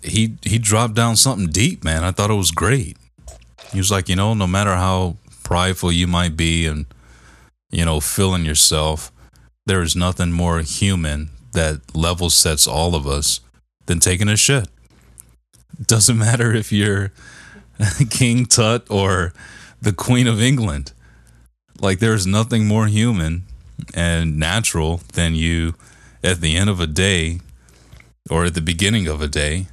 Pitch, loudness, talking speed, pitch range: 90 Hz, -17 LUFS, 155 wpm, 80-105 Hz